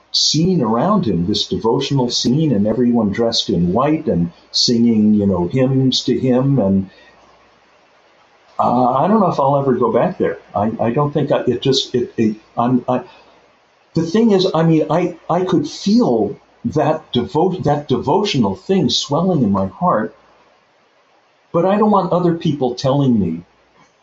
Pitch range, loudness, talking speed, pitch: 120-165 Hz, -16 LUFS, 160 wpm, 135 Hz